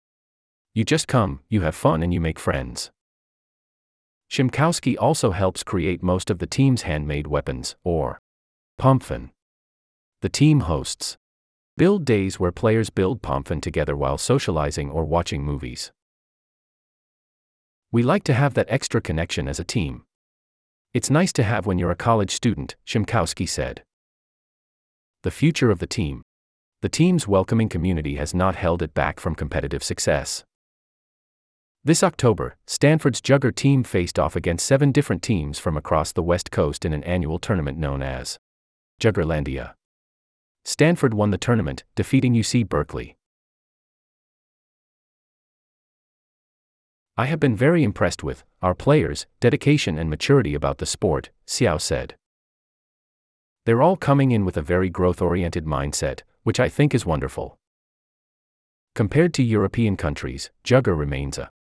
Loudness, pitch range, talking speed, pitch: -22 LUFS, 75-120 Hz, 140 wpm, 90 Hz